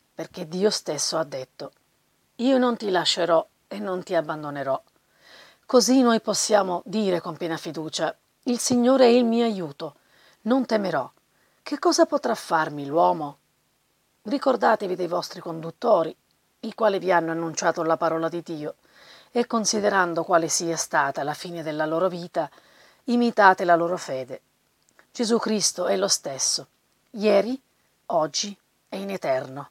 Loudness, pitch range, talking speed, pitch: -23 LUFS, 165-225 Hz, 140 wpm, 185 Hz